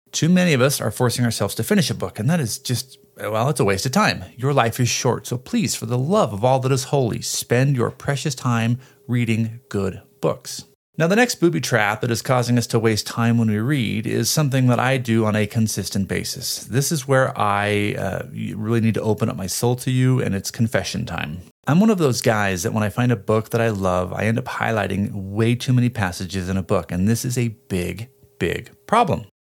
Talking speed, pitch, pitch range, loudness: 235 wpm, 115 Hz, 105-130 Hz, -21 LUFS